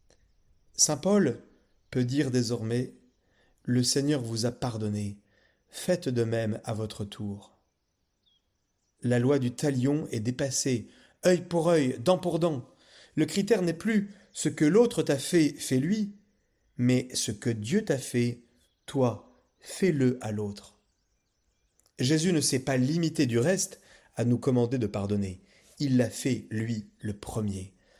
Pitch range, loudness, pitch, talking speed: 110-155 Hz, -28 LUFS, 125 Hz, 140 wpm